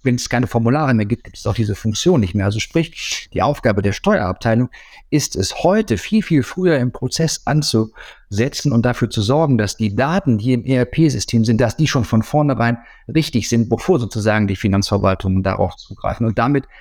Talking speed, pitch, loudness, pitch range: 195 wpm, 120 Hz, -18 LUFS, 110-140 Hz